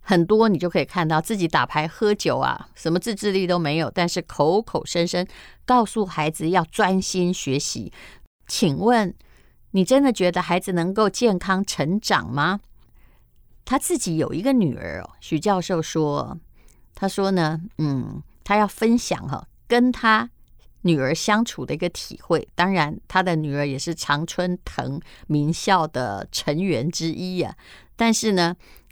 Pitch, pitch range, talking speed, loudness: 180 Hz, 155-205 Hz, 230 characters per minute, -22 LUFS